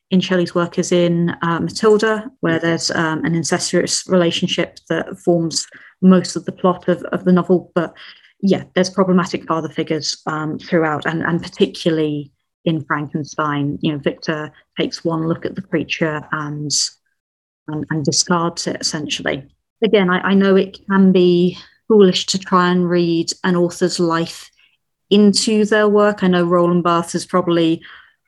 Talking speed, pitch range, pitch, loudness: 160 wpm, 165-185 Hz, 175 Hz, -17 LUFS